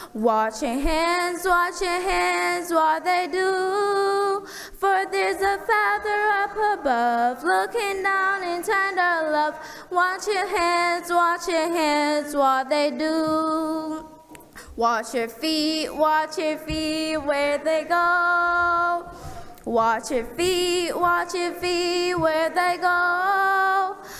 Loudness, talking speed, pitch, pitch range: -22 LUFS, 115 wpm, 345 Hz, 310-375 Hz